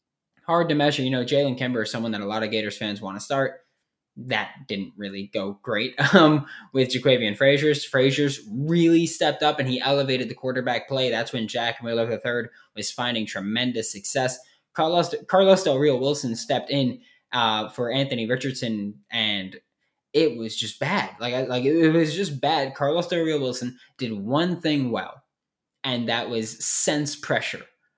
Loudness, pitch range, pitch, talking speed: -23 LUFS, 115-145 Hz, 130 Hz, 175 wpm